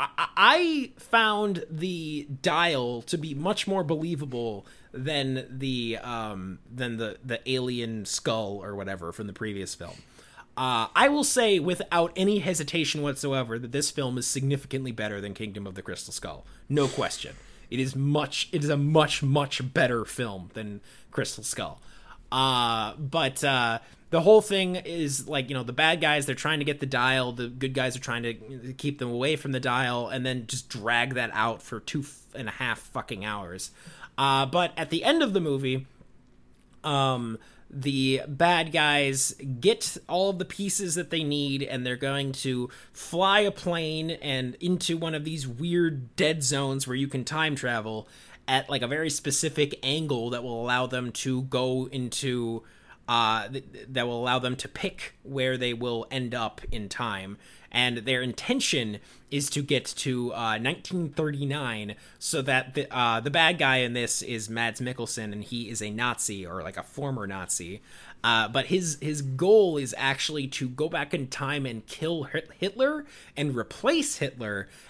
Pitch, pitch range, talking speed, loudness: 135 Hz, 120-155 Hz, 175 wpm, -27 LUFS